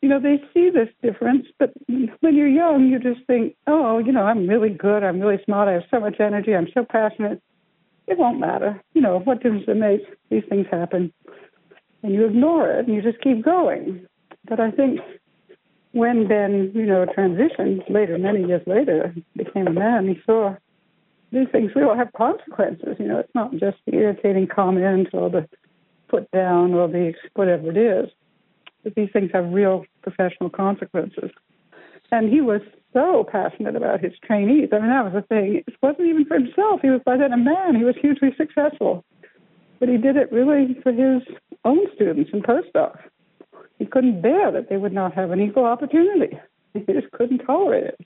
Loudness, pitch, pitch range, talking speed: -20 LUFS, 225 Hz, 195-270 Hz, 190 wpm